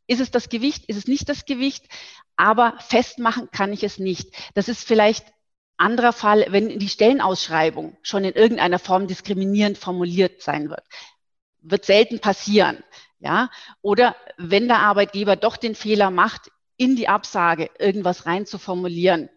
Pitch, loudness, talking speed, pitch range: 205 Hz, -20 LUFS, 150 wpm, 190-235 Hz